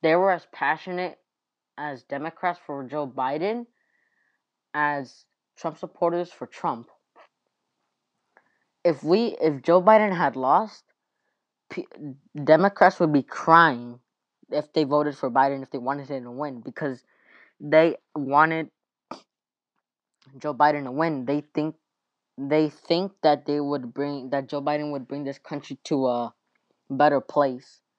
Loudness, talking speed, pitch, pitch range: -24 LUFS, 135 wpm, 150 Hz, 140-165 Hz